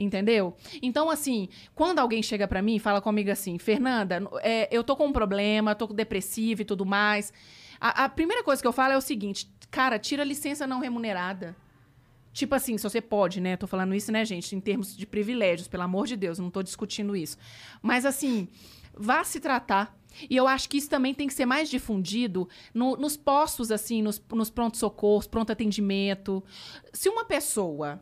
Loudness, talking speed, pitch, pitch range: -27 LUFS, 195 wpm, 215 Hz, 195-260 Hz